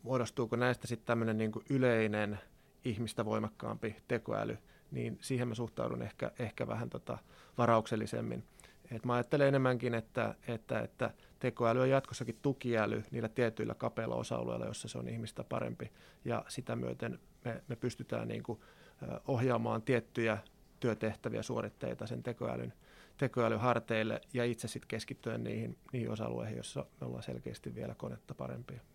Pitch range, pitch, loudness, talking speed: 110-125 Hz, 115 Hz, -37 LUFS, 140 wpm